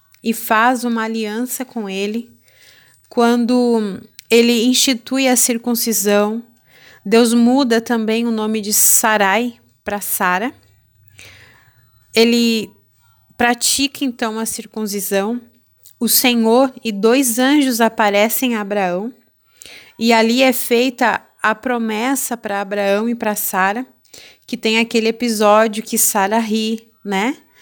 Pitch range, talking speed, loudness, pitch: 205-240 Hz, 115 wpm, -16 LUFS, 225 Hz